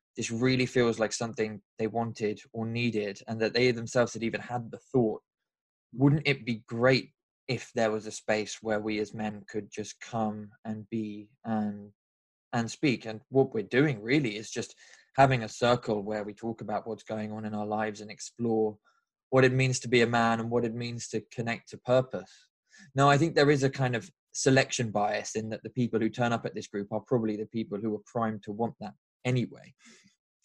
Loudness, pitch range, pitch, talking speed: -29 LUFS, 105-125 Hz, 115 Hz, 210 wpm